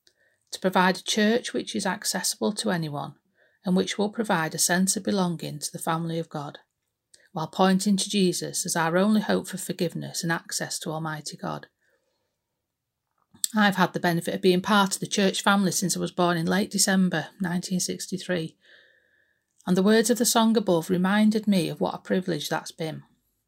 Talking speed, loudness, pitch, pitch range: 180 wpm, -25 LUFS, 185 Hz, 170-200 Hz